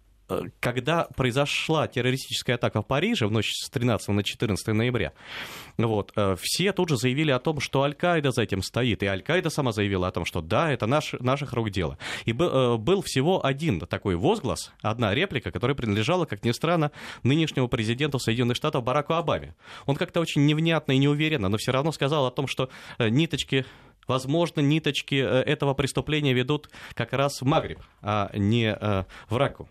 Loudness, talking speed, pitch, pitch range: -25 LUFS, 170 wpm, 130 Hz, 115-150 Hz